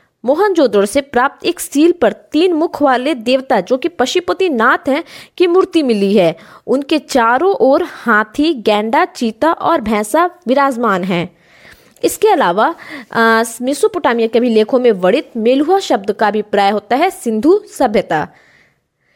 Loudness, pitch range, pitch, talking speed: -14 LUFS, 225-330 Hz, 260 Hz, 140 wpm